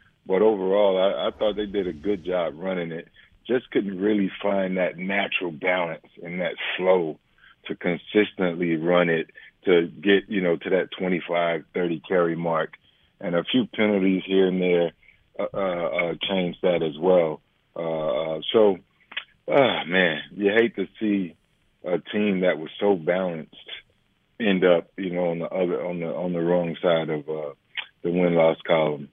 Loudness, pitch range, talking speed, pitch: -24 LUFS, 85-100 Hz, 170 wpm, 90 Hz